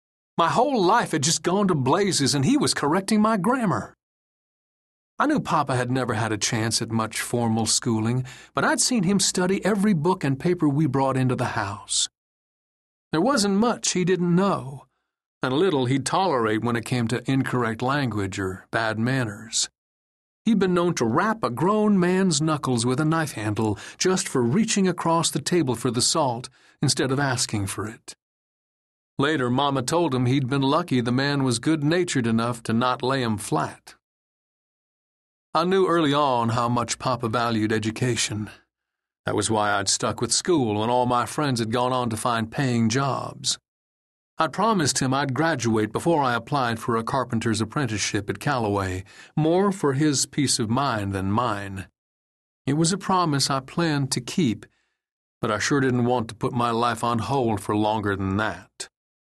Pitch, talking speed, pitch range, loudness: 125 Hz, 180 wpm, 115-155 Hz, -23 LUFS